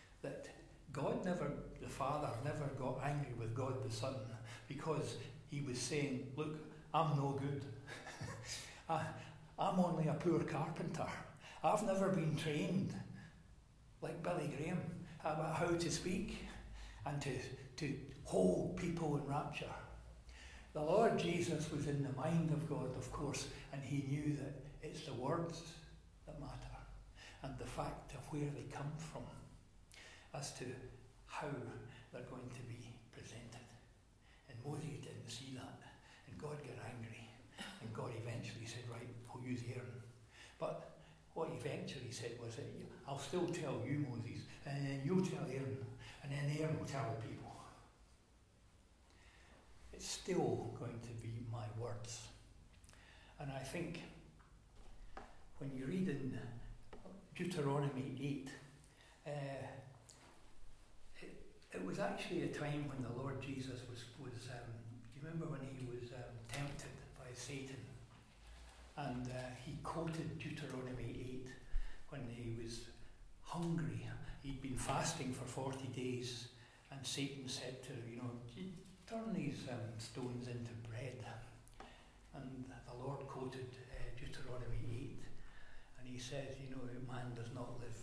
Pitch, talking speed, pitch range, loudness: 130 Hz, 135 wpm, 120-145 Hz, -44 LUFS